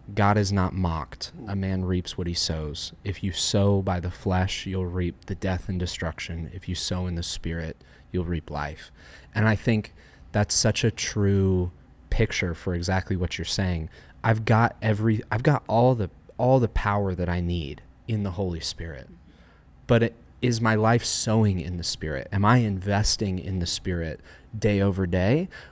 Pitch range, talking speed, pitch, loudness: 85-105 Hz, 185 wpm, 95 Hz, -25 LUFS